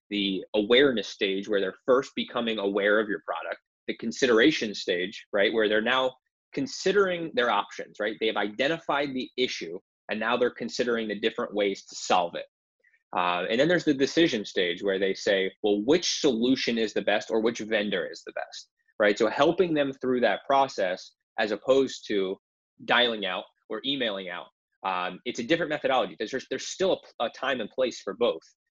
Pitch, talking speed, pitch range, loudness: 125 Hz, 190 wpm, 105-165 Hz, -26 LUFS